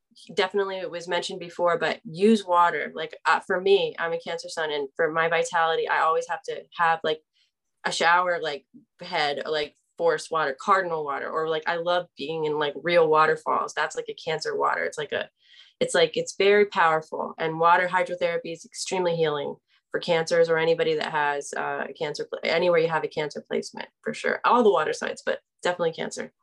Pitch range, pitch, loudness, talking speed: 160-230 Hz, 175 Hz, -25 LUFS, 200 wpm